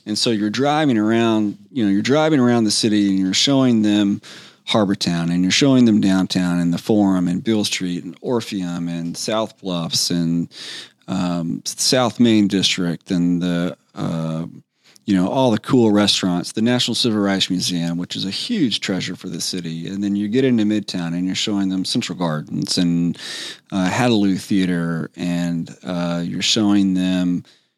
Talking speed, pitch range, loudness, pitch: 175 wpm, 90-110 Hz, -19 LUFS, 95 Hz